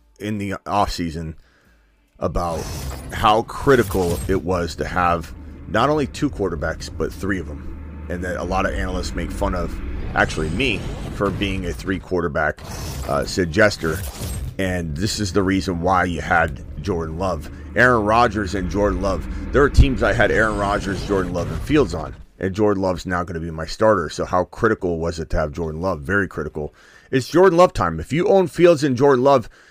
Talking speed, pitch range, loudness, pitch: 190 wpm, 80-100 Hz, -20 LUFS, 90 Hz